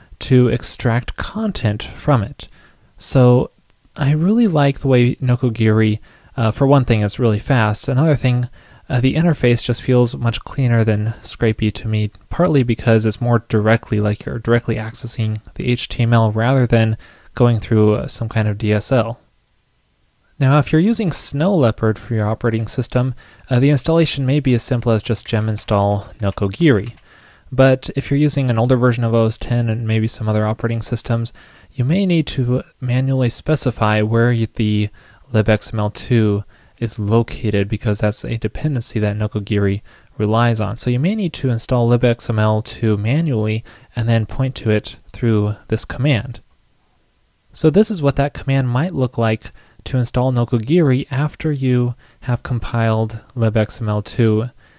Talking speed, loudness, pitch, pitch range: 155 wpm, -17 LUFS, 115 Hz, 110-130 Hz